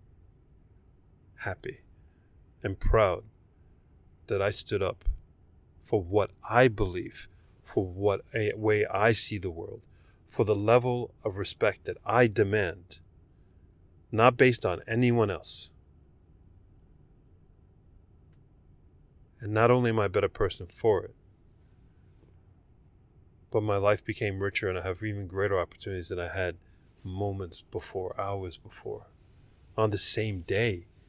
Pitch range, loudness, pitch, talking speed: 90-110 Hz, -28 LUFS, 95 Hz, 125 wpm